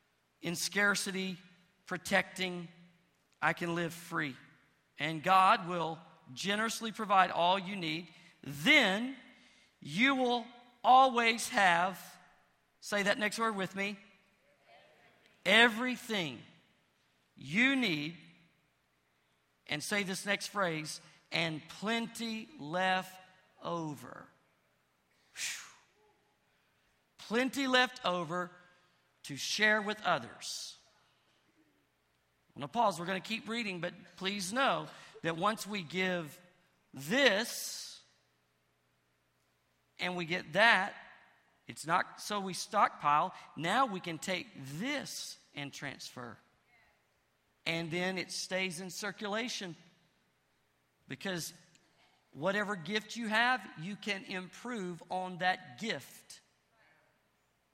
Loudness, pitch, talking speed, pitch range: -33 LUFS, 180 Hz, 100 wpm, 155-205 Hz